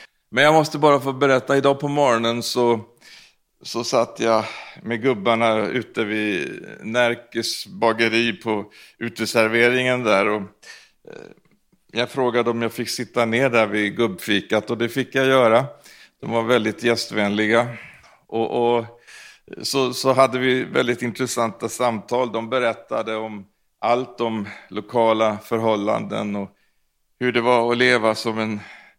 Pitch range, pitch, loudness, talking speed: 110-125 Hz, 115 Hz, -20 LUFS, 135 wpm